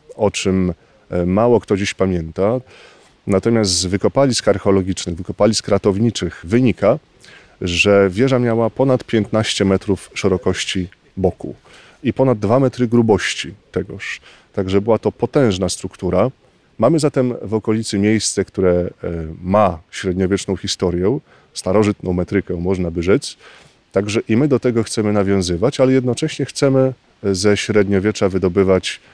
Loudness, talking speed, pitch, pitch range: -17 LUFS, 125 wpm, 100 Hz, 95-115 Hz